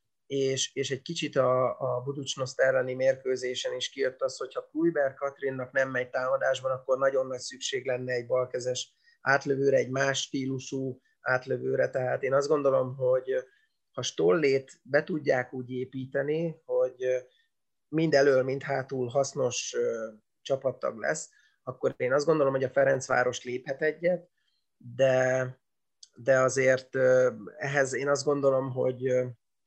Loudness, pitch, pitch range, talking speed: -28 LUFS, 135 Hz, 130-150 Hz, 130 wpm